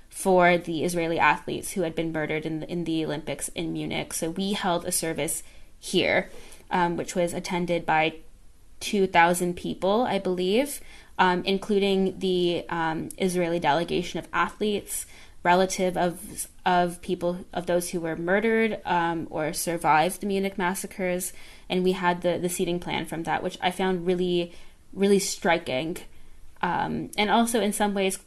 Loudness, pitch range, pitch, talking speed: -26 LUFS, 170-190 Hz, 175 Hz, 160 wpm